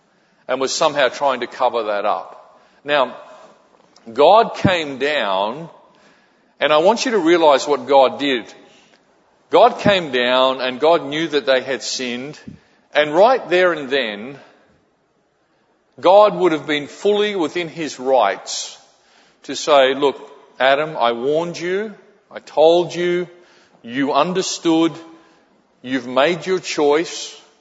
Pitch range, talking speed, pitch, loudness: 135-175 Hz, 130 wpm, 155 Hz, -17 LUFS